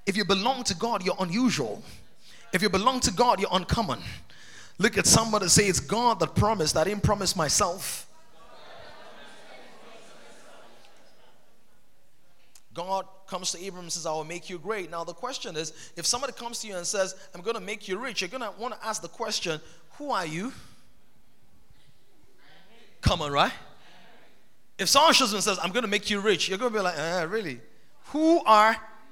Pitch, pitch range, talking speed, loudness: 200 Hz, 175-230 Hz, 185 wpm, -26 LUFS